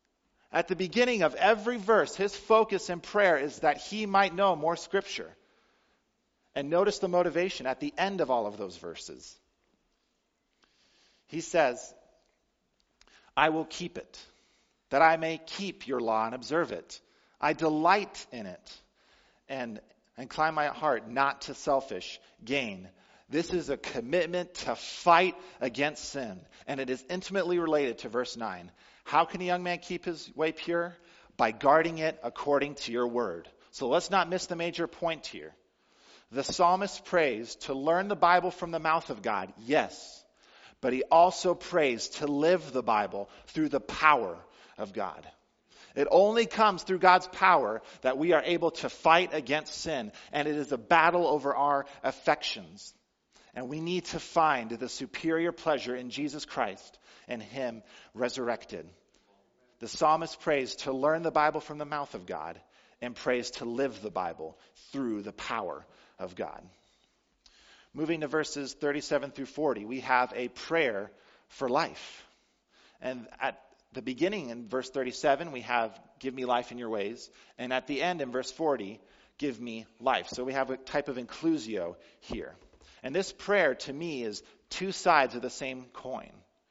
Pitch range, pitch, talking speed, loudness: 130-175 Hz, 155 Hz, 165 wpm, -30 LUFS